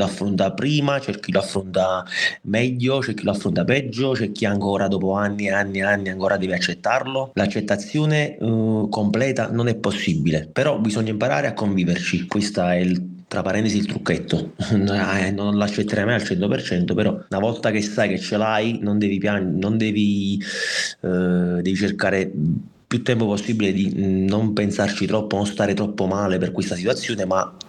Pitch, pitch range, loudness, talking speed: 105 Hz, 95-110 Hz, -21 LUFS, 170 wpm